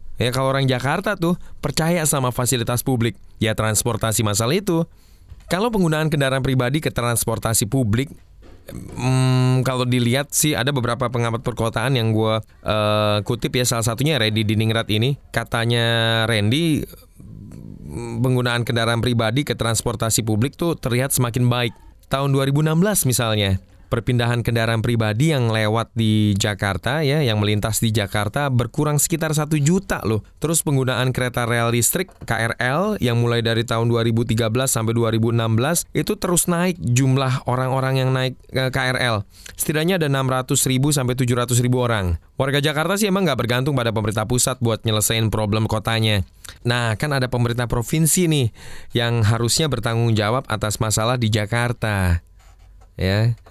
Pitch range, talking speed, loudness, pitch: 110-135 Hz, 145 wpm, -20 LUFS, 120 Hz